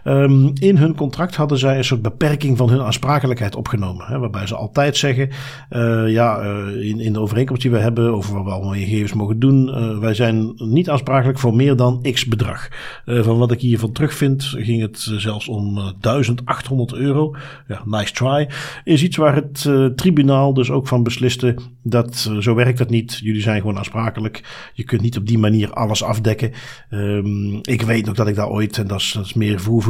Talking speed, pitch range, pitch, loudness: 215 wpm, 110-135 Hz, 120 Hz, -18 LUFS